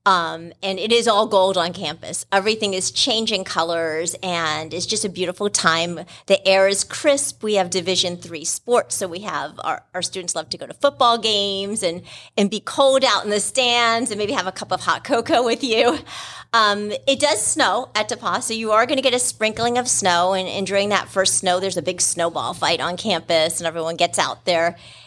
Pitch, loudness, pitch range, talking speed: 195 Hz, -19 LUFS, 175-220 Hz, 220 wpm